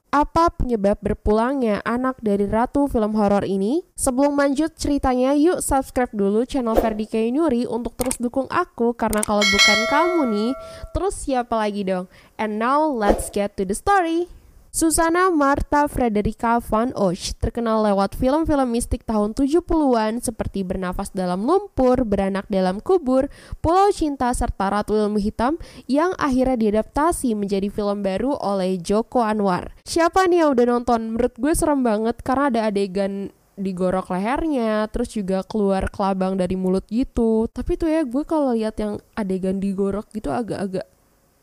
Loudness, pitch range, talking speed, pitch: -21 LUFS, 205-280 Hz, 150 wpm, 230 Hz